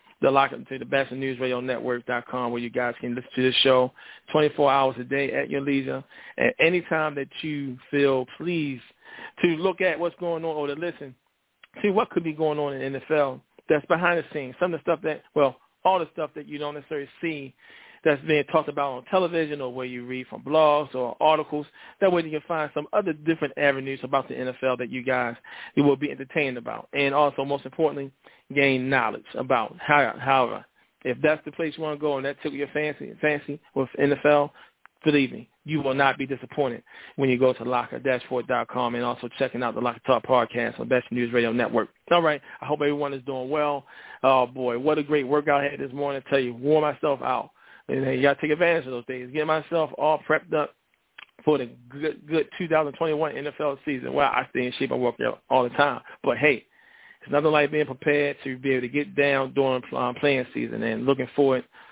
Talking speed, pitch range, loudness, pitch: 220 wpm, 130-155 Hz, -25 LUFS, 140 Hz